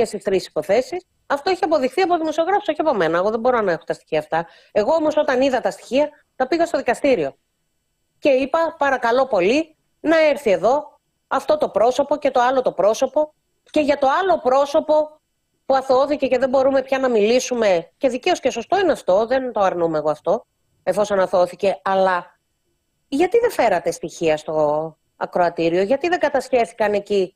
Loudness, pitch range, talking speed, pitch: -19 LUFS, 195-300 Hz, 180 wpm, 265 Hz